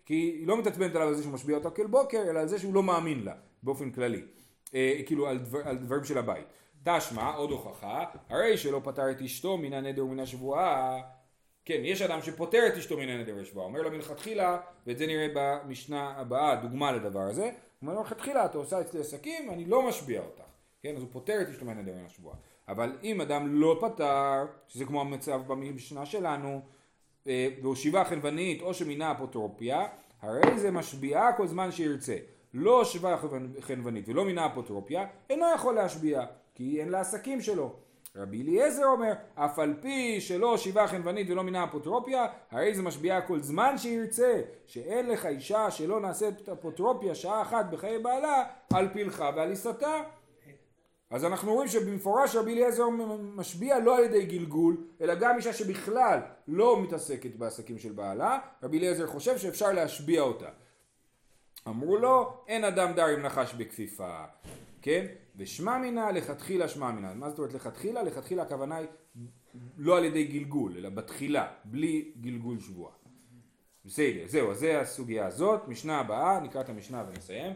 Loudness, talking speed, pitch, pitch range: -30 LUFS, 160 wpm, 160 Hz, 135-210 Hz